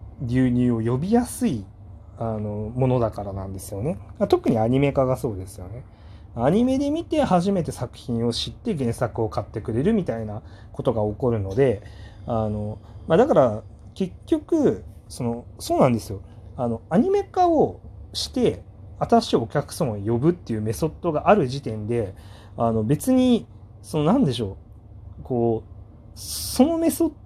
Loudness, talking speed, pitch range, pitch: -23 LUFS, 305 characters per minute, 105-150 Hz, 115 Hz